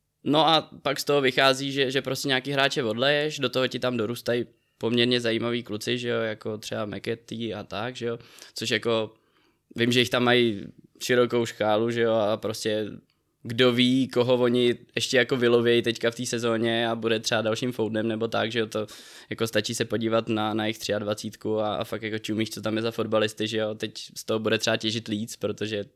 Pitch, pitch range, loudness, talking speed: 115 Hz, 110-120 Hz, -25 LUFS, 210 wpm